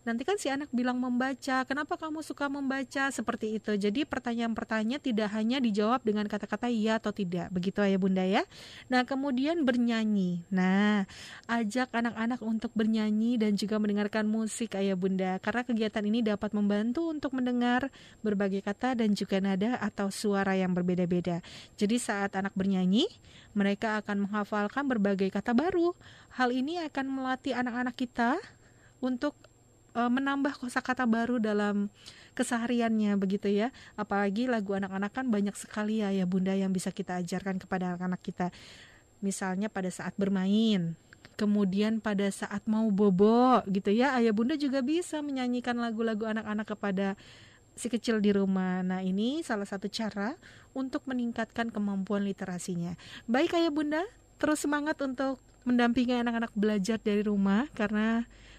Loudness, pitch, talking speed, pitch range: -30 LUFS, 220 Hz, 145 wpm, 200-250 Hz